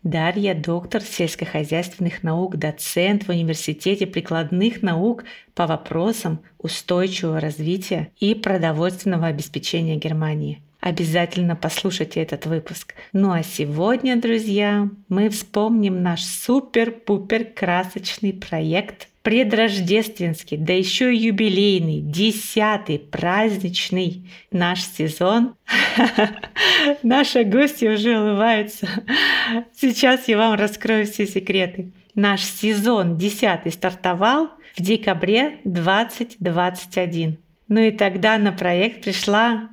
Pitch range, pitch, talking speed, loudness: 175-220 Hz, 195 Hz, 95 wpm, -20 LUFS